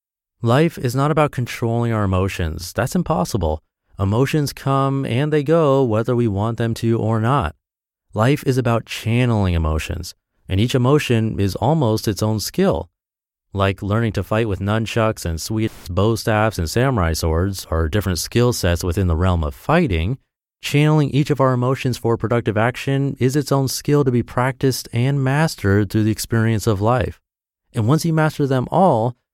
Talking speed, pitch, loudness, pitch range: 170 wpm, 115 Hz, -19 LUFS, 100-135 Hz